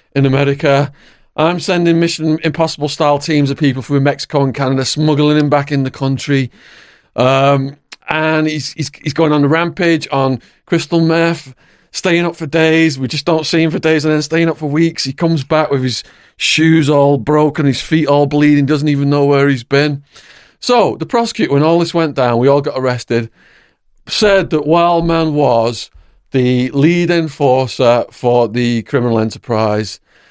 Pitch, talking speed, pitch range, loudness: 145 Hz, 175 wpm, 135-160 Hz, -13 LUFS